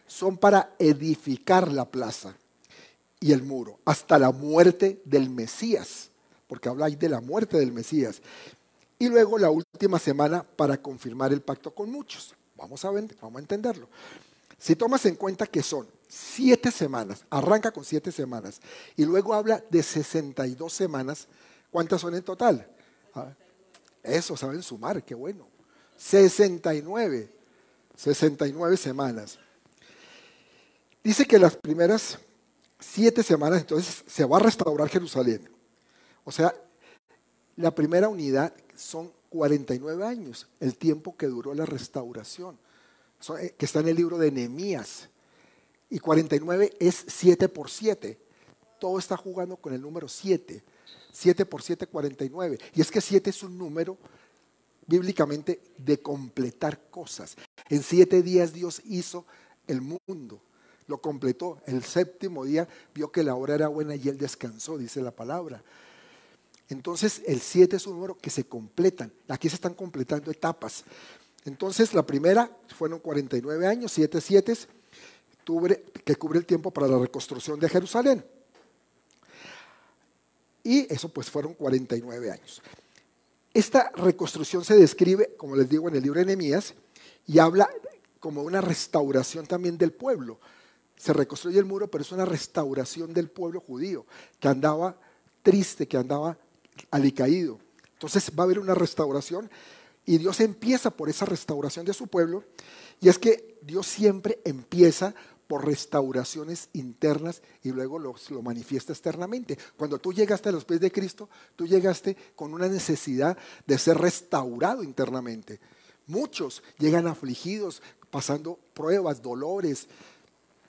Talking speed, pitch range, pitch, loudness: 140 wpm, 140-190 Hz, 165 Hz, -26 LUFS